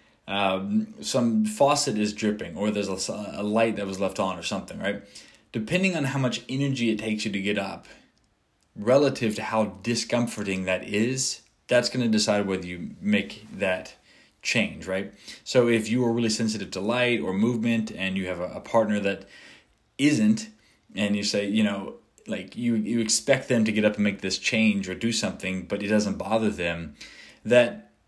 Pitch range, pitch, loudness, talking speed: 100-120 Hz, 110 Hz, -25 LUFS, 190 wpm